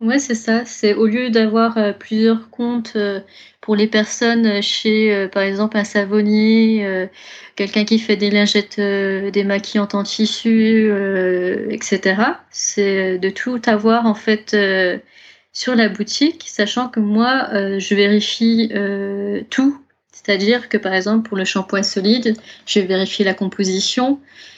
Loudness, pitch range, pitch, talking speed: -17 LUFS, 200-225 Hz, 210 Hz, 130 wpm